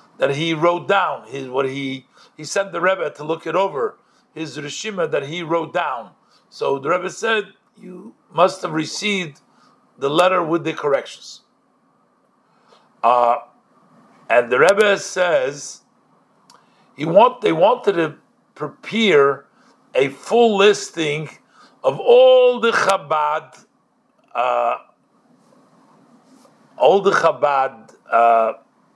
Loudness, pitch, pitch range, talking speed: -18 LUFS, 190 Hz, 160-235 Hz, 120 wpm